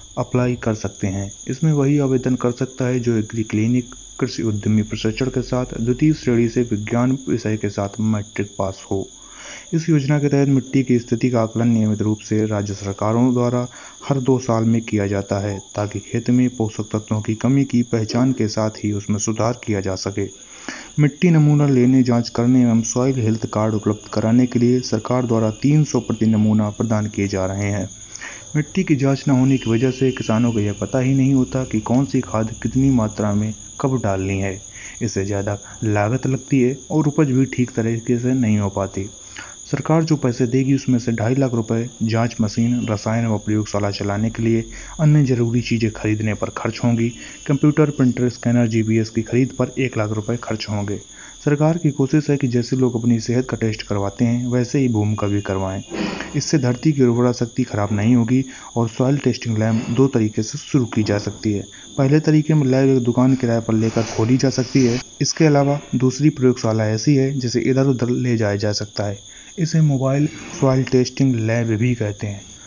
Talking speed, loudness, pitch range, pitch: 195 wpm, -19 LUFS, 110-130 Hz, 120 Hz